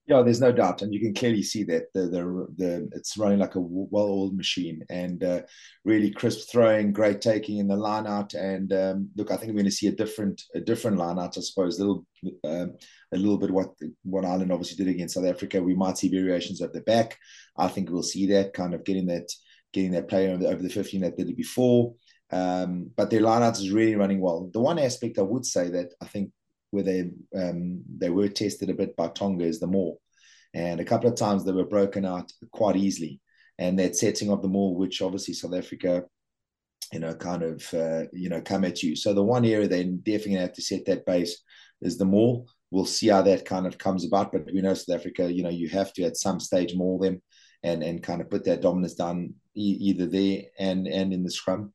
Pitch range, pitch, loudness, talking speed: 90-100 Hz, 95 Hz, -26 LUFS, 230 wpm